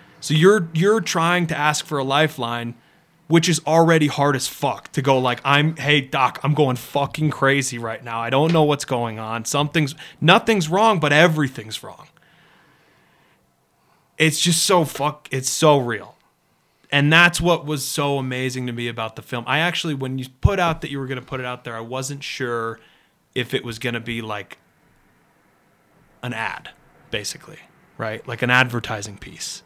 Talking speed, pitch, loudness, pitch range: 180 wpm, 140 Hz, -20 LUFS, 125-160 Hz